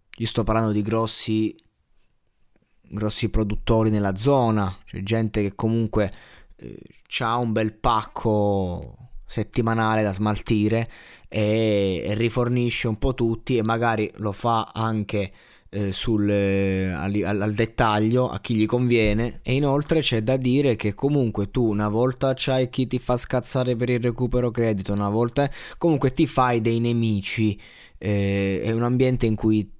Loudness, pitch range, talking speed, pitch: -23 LUFS, 105-125 Hz, 150 wpm, 110 Hz